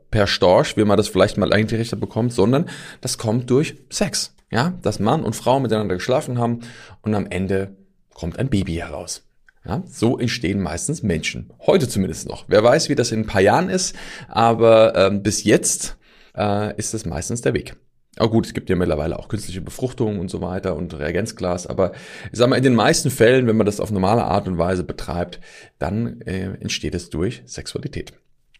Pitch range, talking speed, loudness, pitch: 95-115 Hz, 200 wpm, -20 LUFS, 105 Hz